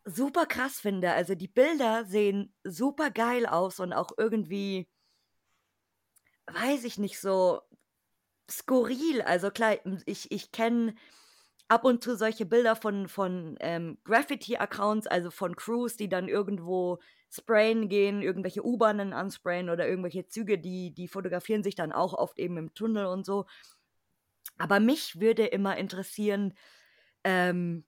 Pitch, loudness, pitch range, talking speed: 200 Hz, -29 LUFS, 180-225 Hz, 140 wpm